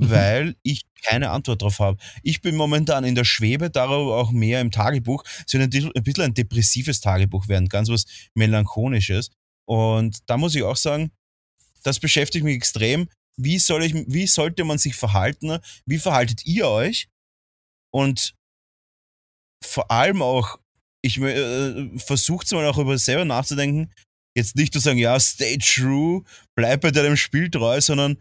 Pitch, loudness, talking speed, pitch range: 130 Hz, -20 LUFS, 160 wpm, 110-150 Hz